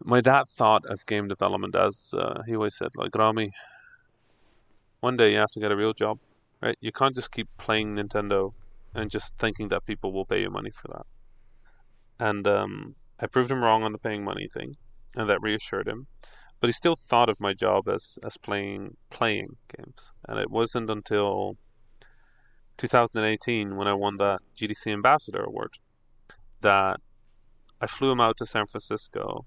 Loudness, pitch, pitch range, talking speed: -26 LUFS, 110 Hz, 100-115 Hz, 175 wpm